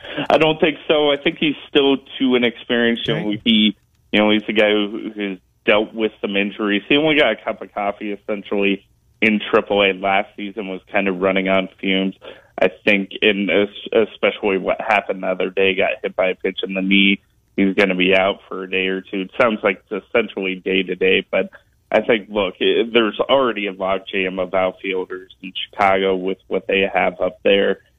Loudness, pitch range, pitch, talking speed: -18 LUFS, 95-110 Hz, 100 Hz, 200 wpm